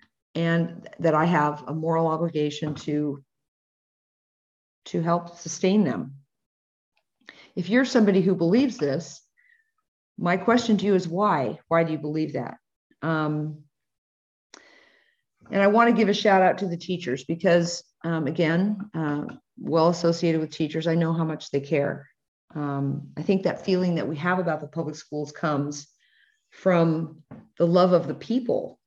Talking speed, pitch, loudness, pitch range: 155 wpm, 165 Hz, -24 LUFS, 150-185 Hz